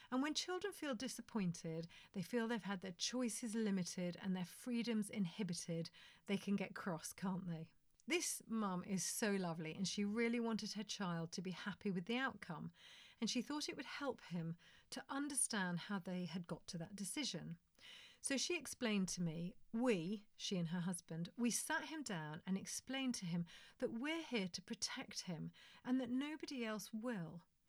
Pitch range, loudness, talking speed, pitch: 180-245 Hz, -44 LUFS, 180 wpm, 205 Hz